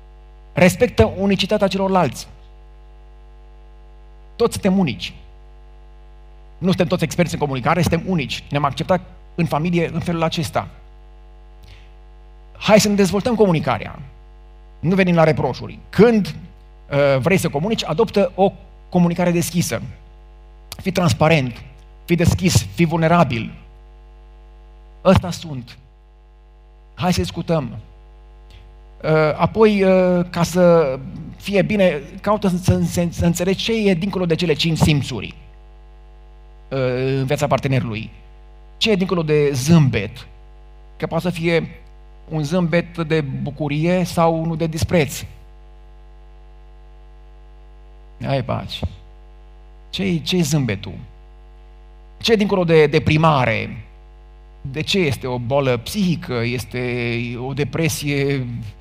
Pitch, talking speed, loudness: 135 Hz, 105 wpm, -18 LUFS